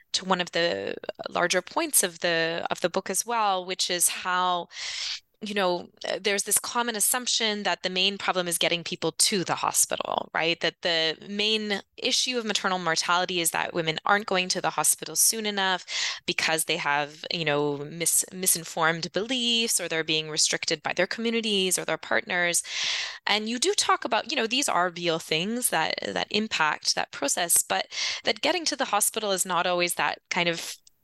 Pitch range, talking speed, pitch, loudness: 165-210 Hz, 185 wpm, 180 Hz, -25 LUFS